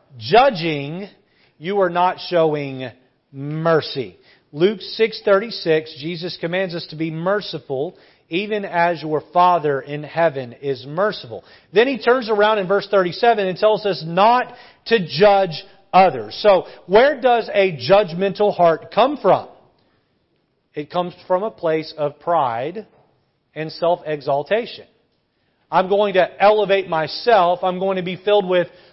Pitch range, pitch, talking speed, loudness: 155-200 Hz, 180 Hz, 135 wpm, -18 LUFS